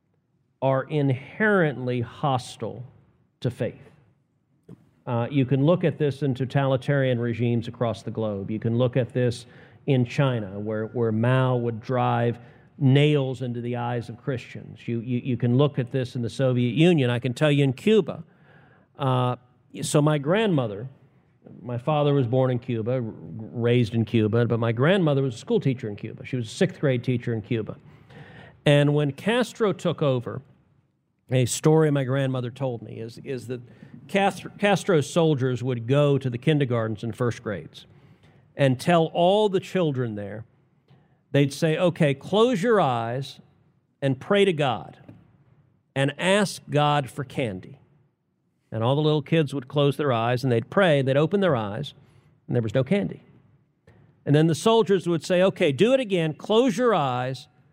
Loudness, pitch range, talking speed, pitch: -24 LUFS, 125-155 Hz, 170 wpm, 135 Hz